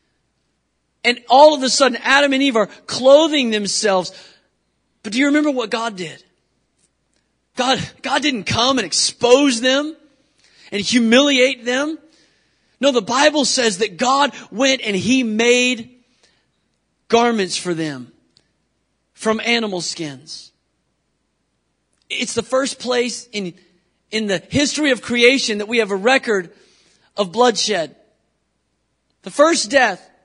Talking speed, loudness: 125 wpm, -16 LUFS